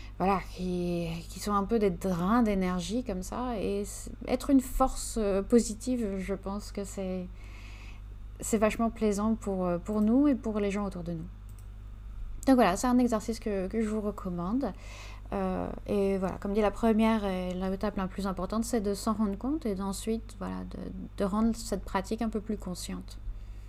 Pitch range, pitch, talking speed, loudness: 175-220 Hz, 200 Hz, 185 wpm, -30 LUFS